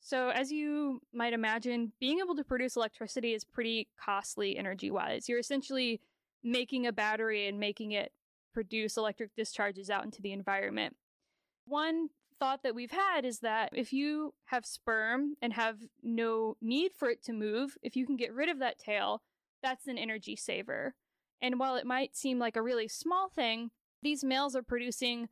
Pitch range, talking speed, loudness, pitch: 225-275 Hz, 180 wpm, -35 LUFS, 245 Hz